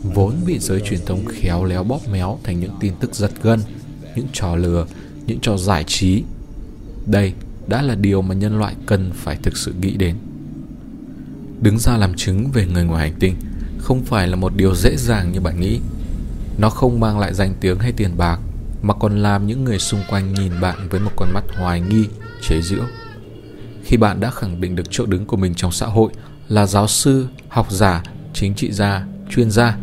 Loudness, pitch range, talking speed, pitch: -19 LUFS, 95-115 Hz, 205 wpm, 100 Hz